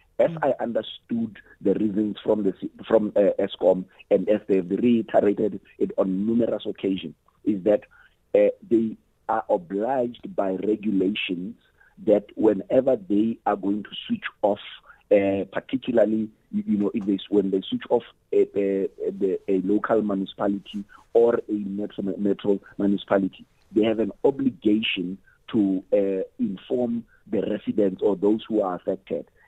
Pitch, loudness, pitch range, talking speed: 105 Hz, -24 LUFS, 100-115 Hz, 140 wpm